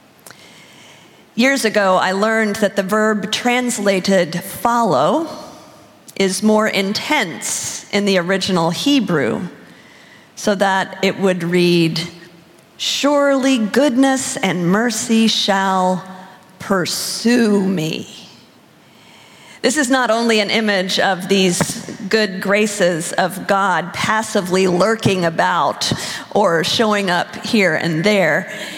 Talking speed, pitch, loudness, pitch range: 100 wpm, 200 Hz, -16 LUFS, 190-225 Hz